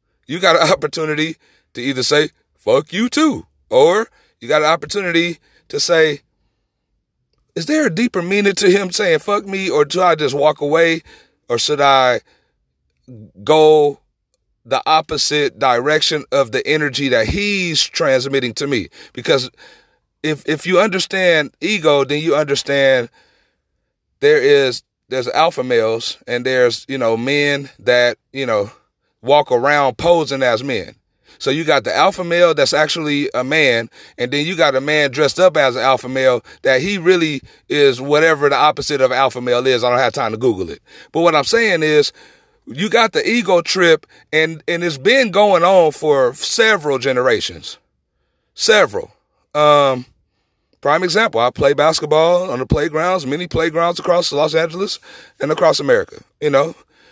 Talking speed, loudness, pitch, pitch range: 160 wpm, -15 LUFS, 155 Hz, 135-185 Hz